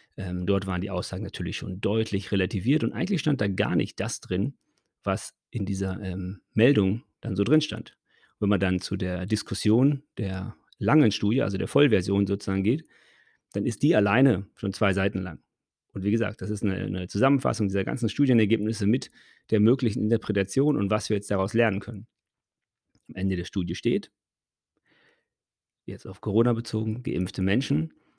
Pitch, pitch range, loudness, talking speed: 105 Hz, 95-115 Hz, -26 LUFS, 170 wpm